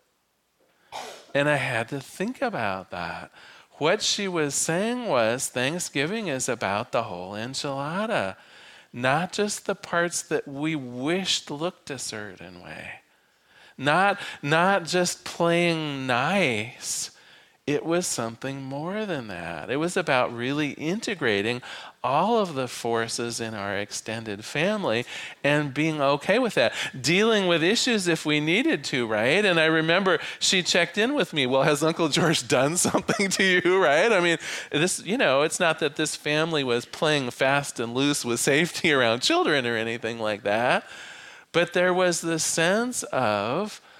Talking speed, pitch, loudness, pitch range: 155 wpm, 155 Hz, -24 LUFS, 130-180 Hz